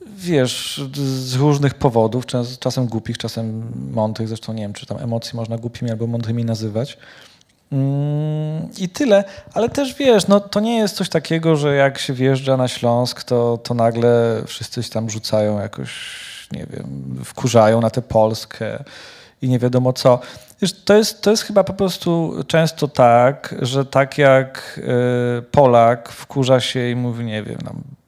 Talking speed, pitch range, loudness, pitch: 165 wpm, 115-150 Hz, -18 LUFS, 125 Hz